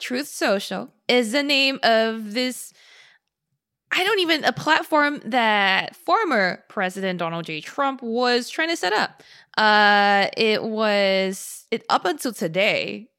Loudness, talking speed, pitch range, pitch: -21 LUFS, 135 wpm, 195-275 Hz, 230 Hz